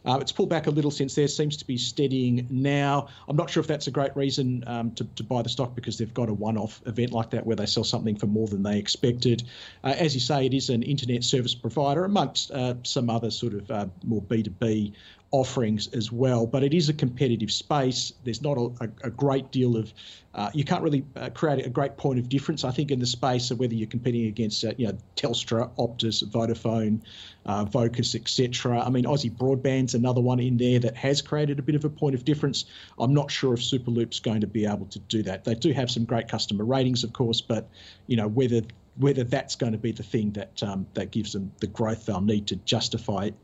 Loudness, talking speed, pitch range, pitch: -26 LUFS, 240 wpm, 110-135 Hz, 120 Hz